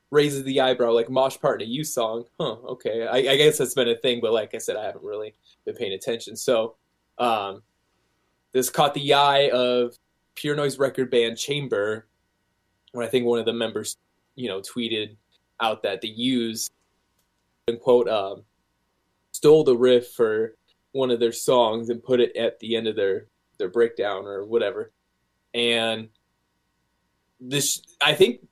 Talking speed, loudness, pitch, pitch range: 175 wpm, -23 LUFS, 120 Hz, 110-150 Hz